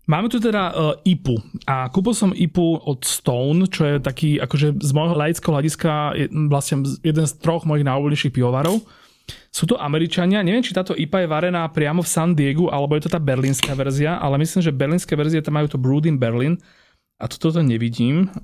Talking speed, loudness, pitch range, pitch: 200 wpm, -20 LUFS, 140-170 Hz, 155 Hz